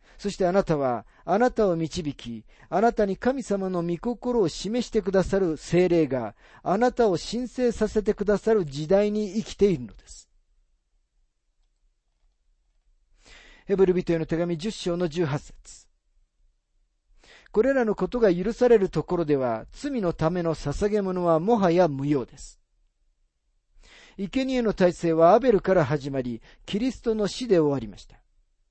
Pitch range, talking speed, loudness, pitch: 150-215 Hz, 270 characters per minute, -24 LUFS, 180 Hz